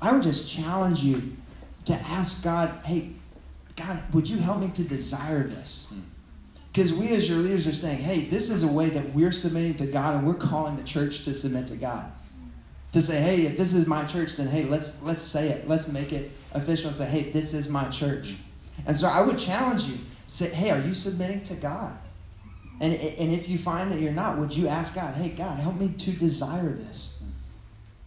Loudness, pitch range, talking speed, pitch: -26 LUFS, 135-175 Hz, 215 wpm, 155 Hz